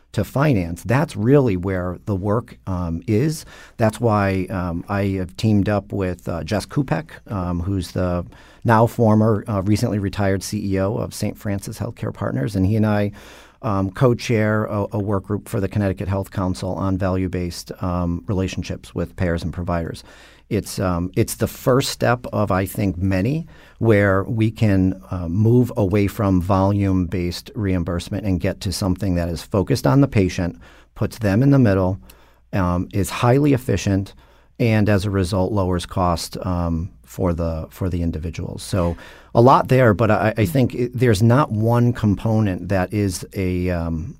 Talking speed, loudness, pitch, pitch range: 170 wpm, -20 LUFS, 100 Hz, 90-110 Hz